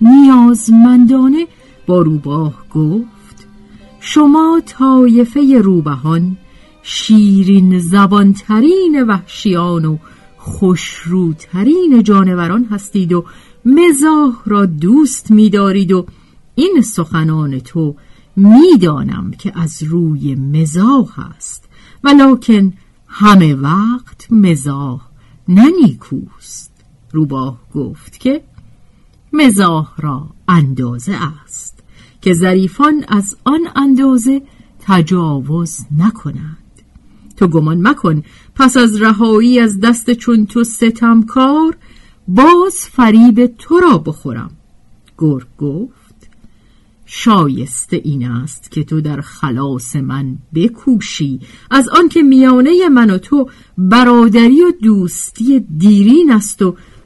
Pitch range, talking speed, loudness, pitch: 155-250 Hz, 95 wpm, -10 LUFS, 200 Hz